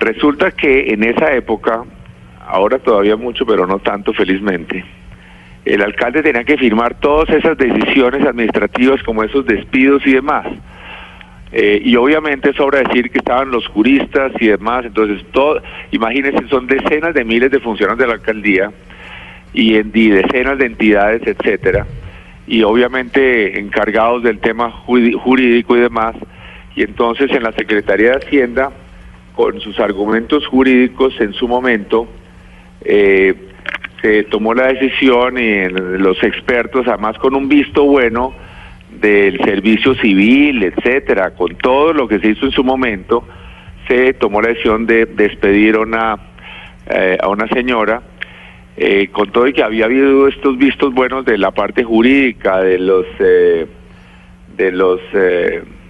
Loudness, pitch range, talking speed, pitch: -13 LUFS, 105-135 Hz, 145 wpm, 120 Hz